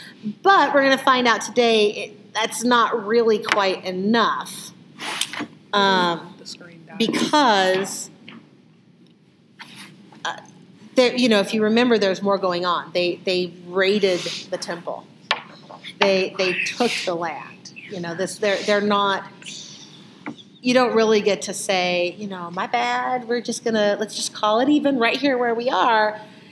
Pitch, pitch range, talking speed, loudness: 205 Hz, 190-230 Hz, 145 wpm, -20 LUFS